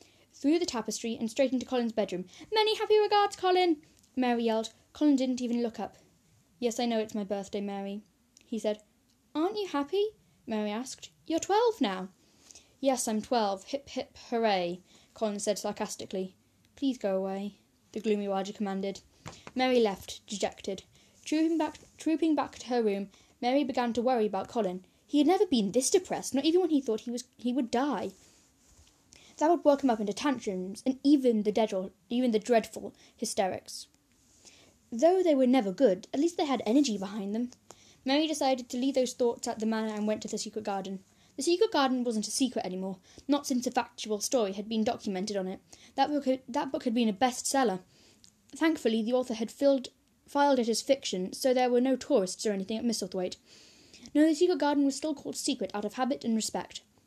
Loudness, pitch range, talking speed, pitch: -30 LUFS, 215-280 Hz, 195 wpm, 245 Hz